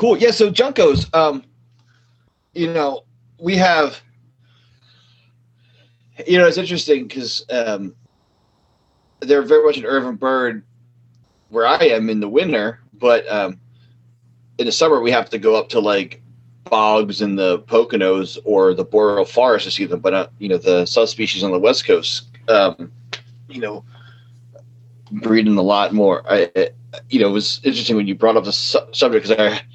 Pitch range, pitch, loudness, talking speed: 115-140 Hz, 120 Hz, -16 LUFS, 165 wpm